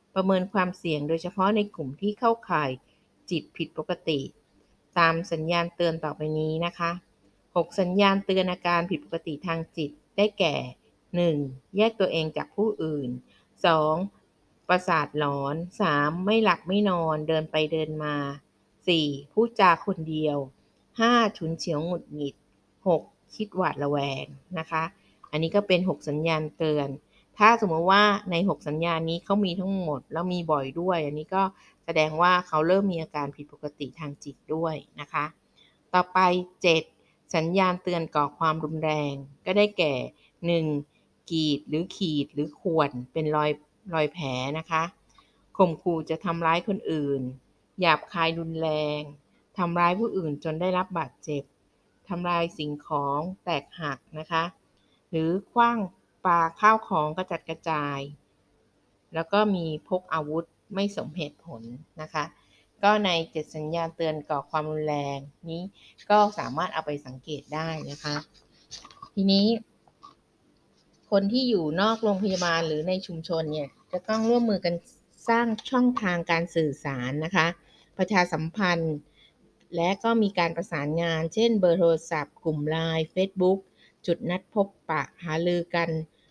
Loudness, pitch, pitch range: -27 LUFS, 165 Hz, 150-185 Hz